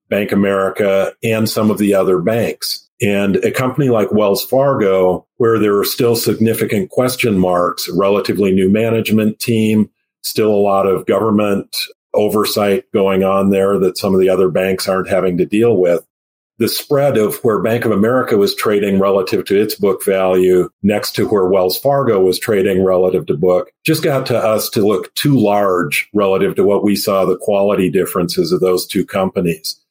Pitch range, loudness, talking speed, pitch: 95-110 Hz, -14 LUFS, 180 wpm, 100 Hz